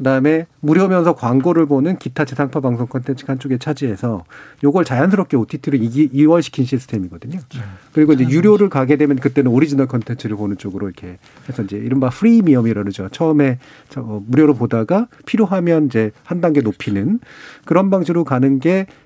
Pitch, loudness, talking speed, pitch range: 140 Hz, -16 LUFS, 410 characters per minute, 120-165 Hz